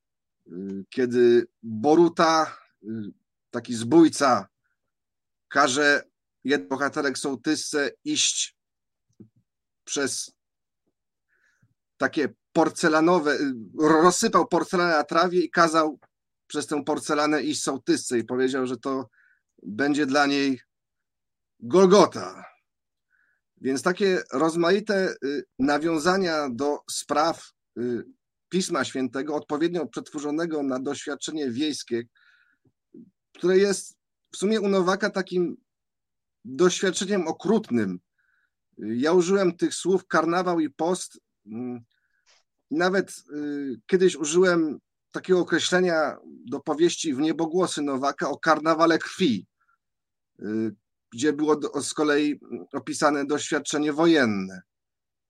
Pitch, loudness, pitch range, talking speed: 155 Hz, -24 LUFS, 140-180 Hz, 85 wpm